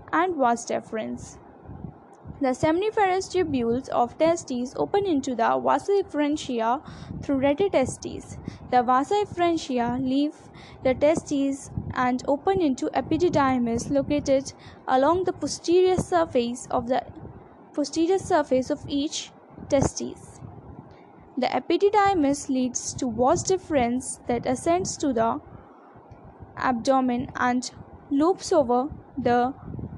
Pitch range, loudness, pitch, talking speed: 255-330 Hz, -24 LUFS, 280 Hz, 105 wpm